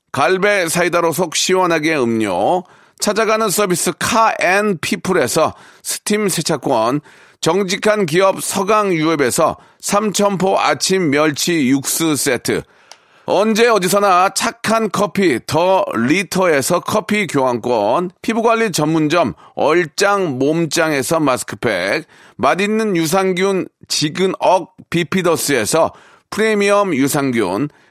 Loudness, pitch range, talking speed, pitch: -16 LUFS, 160-205 Hz, 240 characters per minute, 185 Hz